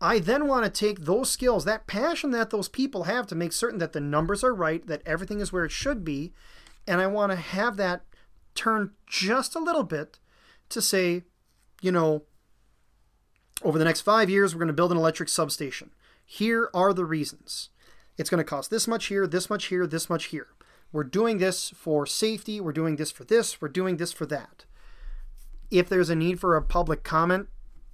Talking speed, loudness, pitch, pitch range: 205 wpm, -26 LUFS, 180 Hz, 160-215 Hz